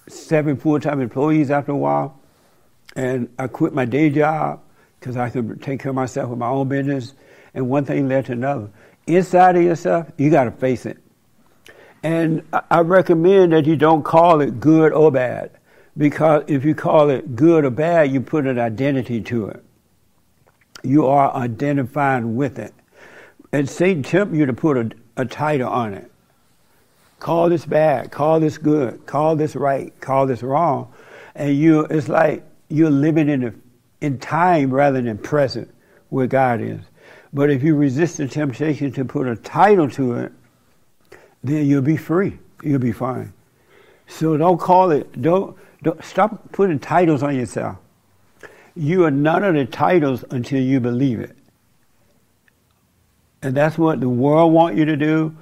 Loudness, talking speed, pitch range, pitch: -18 LUFS, 170 wpm, 130-160 Hz, 145 Hz